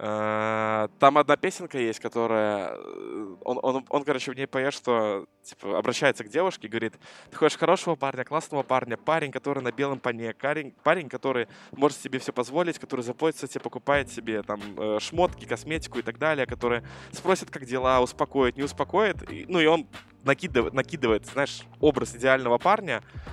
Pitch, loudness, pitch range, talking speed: 130 Hz, -26 LUFS, 120-150 Hz, 165 wpm